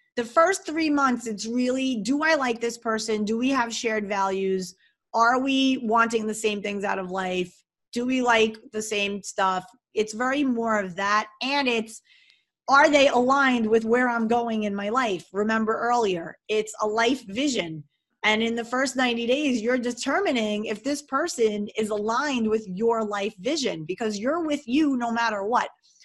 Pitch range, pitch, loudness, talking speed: 215-260 Hz, 230 Hz, -24 LUFS, 180 wpm